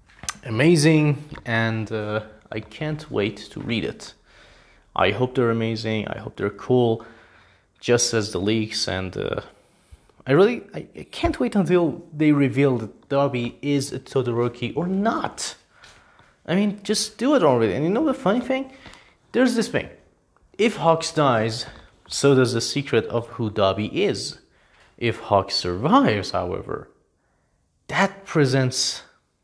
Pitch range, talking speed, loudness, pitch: 110-165 Hz, 145 wpm, -22 LUFS, 125 Hz